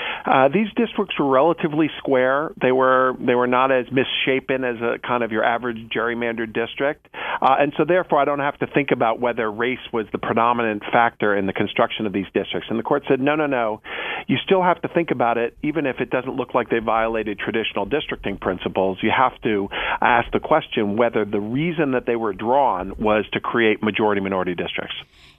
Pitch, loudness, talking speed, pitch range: 120 Hz, -21 LUFS, 210 wpm, 110-140 Hz